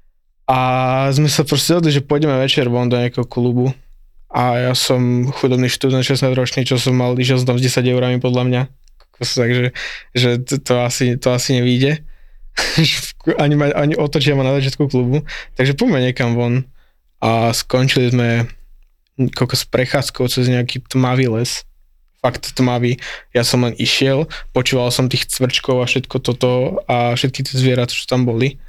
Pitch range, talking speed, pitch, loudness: 125-135 Hz, 165 wpm, 125 Hz, -16 LUFS